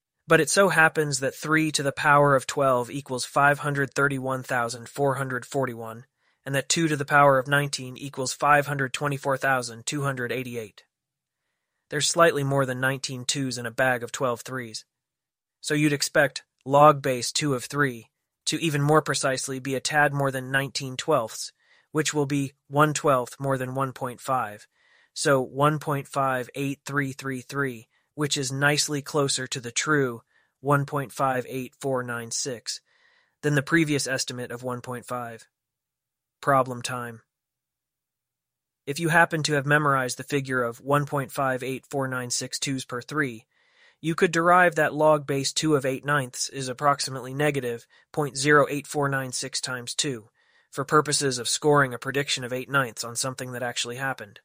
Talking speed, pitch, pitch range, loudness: 135 wpm, 135 Hz, 130-145 Hz, -25 LUFS